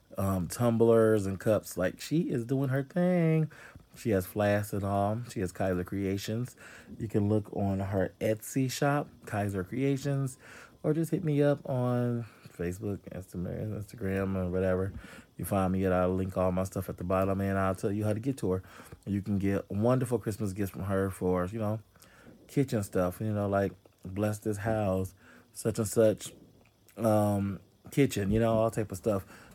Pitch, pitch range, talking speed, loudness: 105 Hz, 95-115 Hz, 185 wpm, -31 LUFS